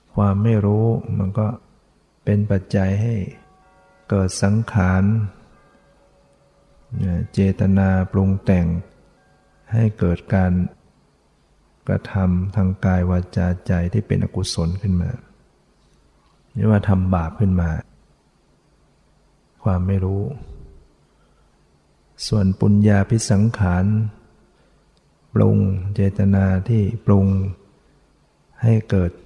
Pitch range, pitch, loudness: 90-105 Hz, 95 Hz, -20 LUFS